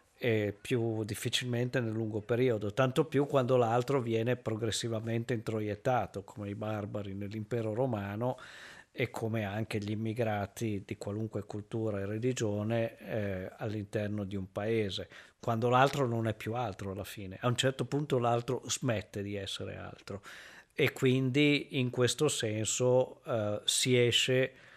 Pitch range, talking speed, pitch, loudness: 105-125 Hz, 140 wpm, 115 Hz, -32 LUFS